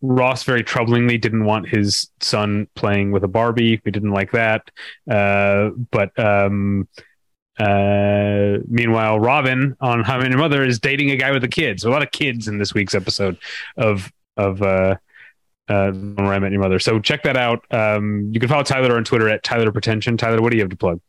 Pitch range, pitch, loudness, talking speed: 100-120 Hz, 110 Hz, -18 LUFS, 210 wpm